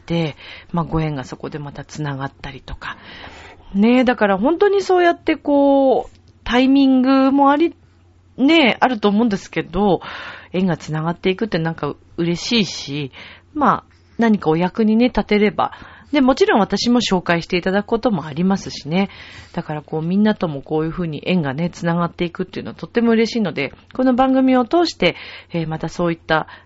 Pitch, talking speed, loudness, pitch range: 185 Hz, 375 characters per minute, -18 LUFS, 160-245 Hz